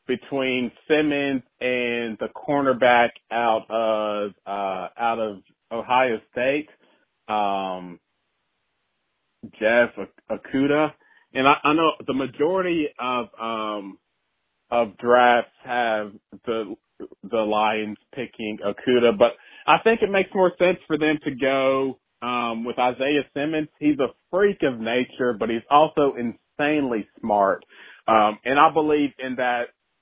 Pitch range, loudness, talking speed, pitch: 110-145 Hz, -22 LUFS, 125 wpm, 125 Hz